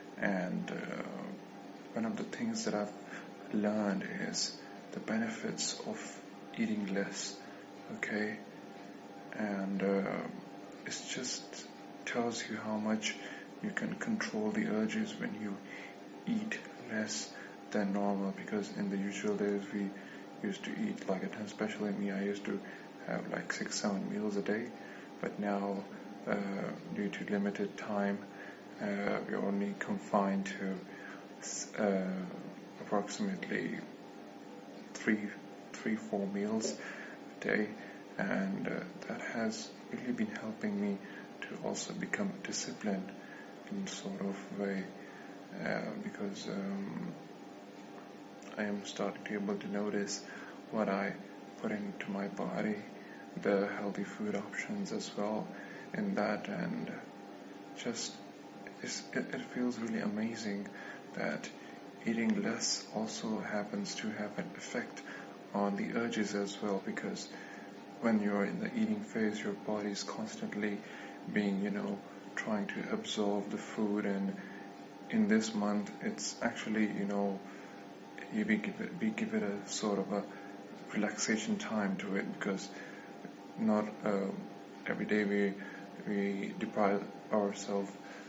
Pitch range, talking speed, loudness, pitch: 100-105 Hz, 130 wpm, -37 LUFS, 100 Hz